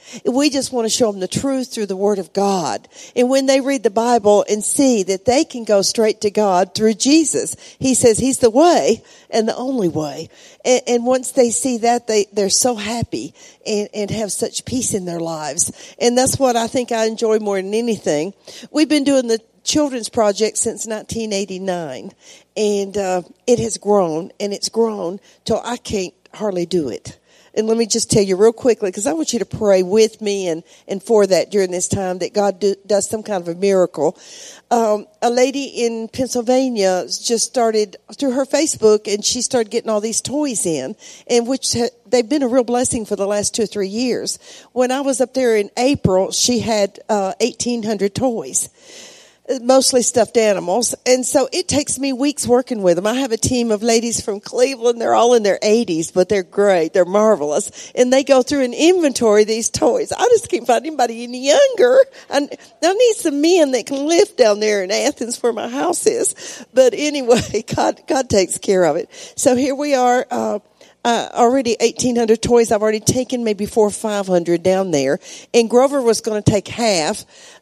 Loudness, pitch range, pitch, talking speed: -17 LUFS, 205-255 Hz, 230 Hz, 200 wpm